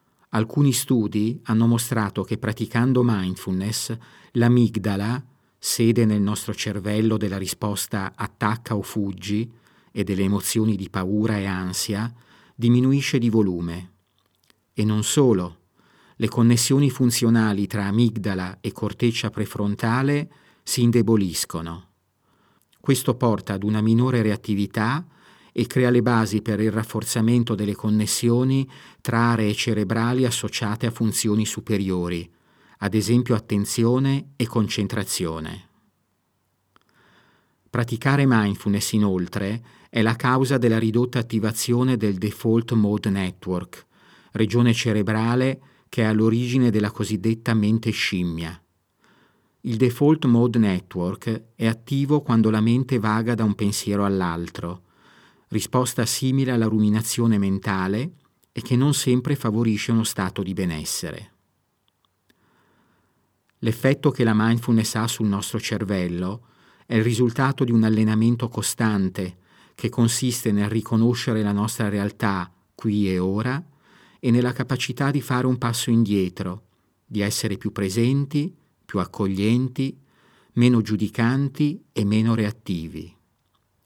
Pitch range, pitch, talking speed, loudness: 100-120 Hz, 110 Hz, 115 wpm, -22 LUFS